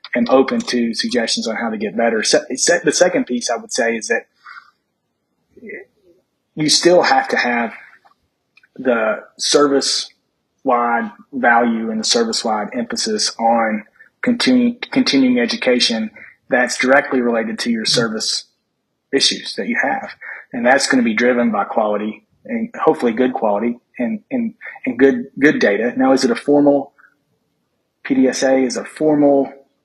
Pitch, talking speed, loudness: 140 Hz, 140 wpm, -16 LUFS